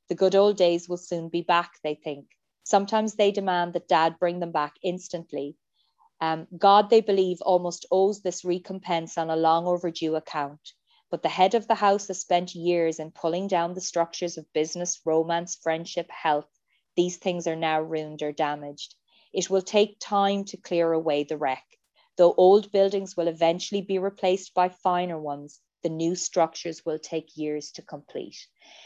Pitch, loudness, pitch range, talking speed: 175 Hz, -25 LUFS, 160-185 Hz, 175 wpm